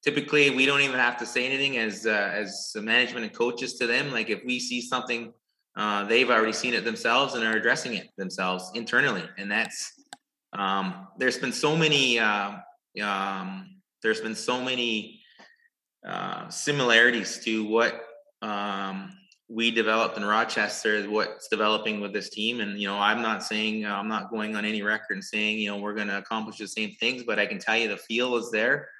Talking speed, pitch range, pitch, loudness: 190 wpm, 105-130 Hz, 115 Hz, -26 LUFS